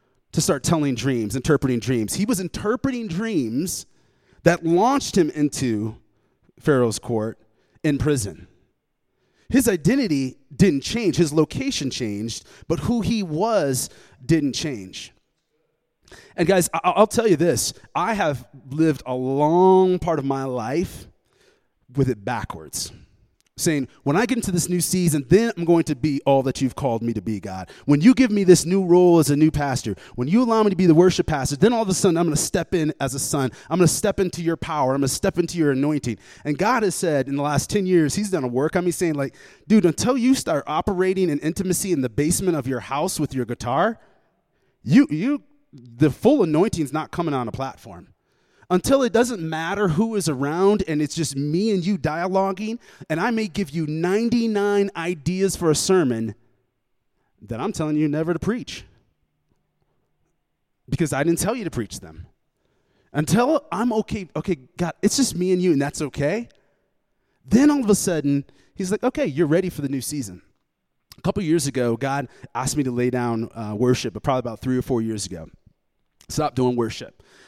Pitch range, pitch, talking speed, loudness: 130-185 Hz, 155 Hz, 195 wpm, -21 LUFS